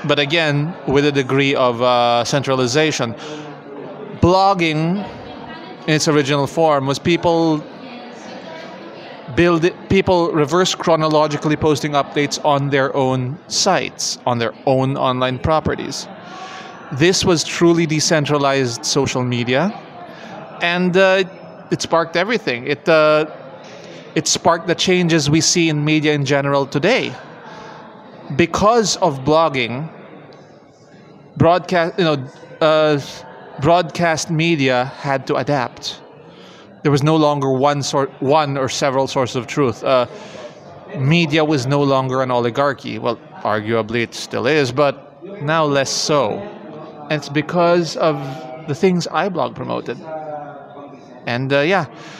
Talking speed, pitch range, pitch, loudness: 125 wpm, 140-170 Hz, 150 Hz, -17 LUFS